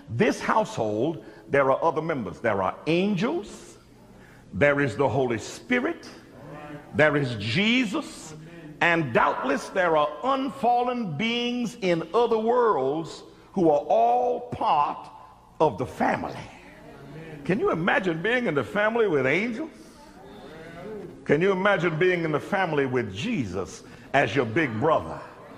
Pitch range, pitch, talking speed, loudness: 150-230 Hz, 180 Hz, 130 wpm, -24 LUFS